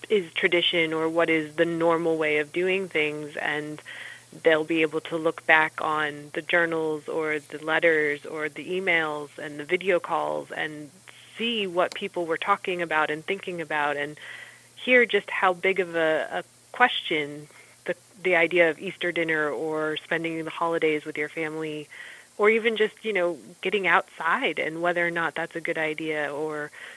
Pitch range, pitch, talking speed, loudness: 155-175 Hz, 160 Hz, 175 wpm, -25 LUFS